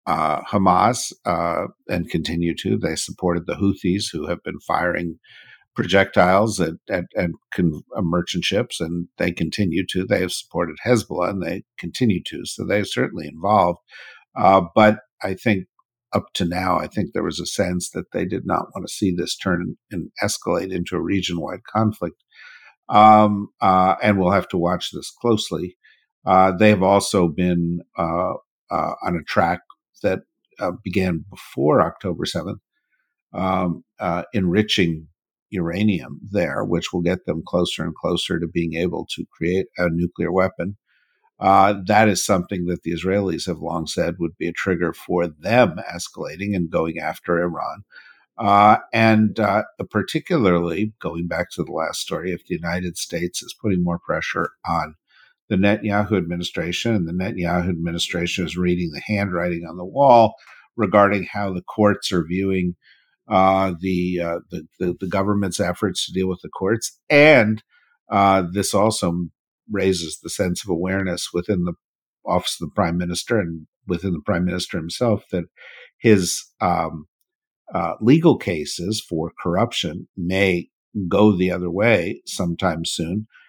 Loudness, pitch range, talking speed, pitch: -21 LUFS, 85-100 Hz, 160 wpm, 90 Hz